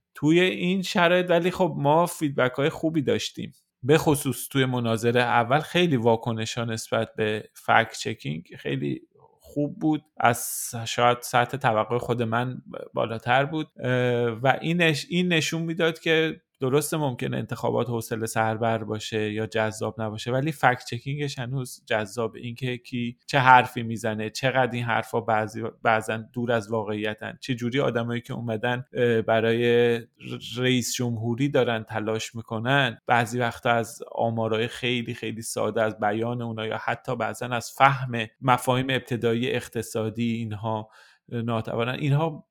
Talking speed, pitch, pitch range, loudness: 140 wpm, 120 Hz, 115-135 Hz, -25 LUFS